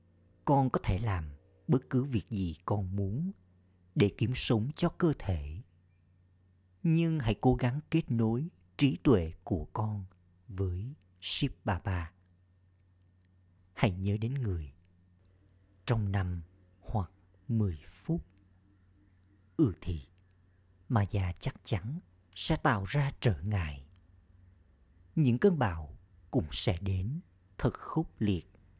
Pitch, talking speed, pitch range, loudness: 95 Hz, 120 wpm, 90-120 Hz, -32 LUFS